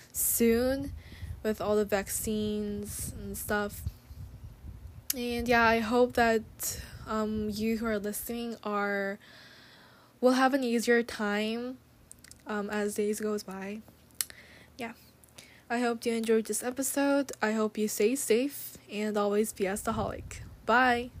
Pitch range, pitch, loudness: 210-240 Hz, 220 Hz, -30 LUFS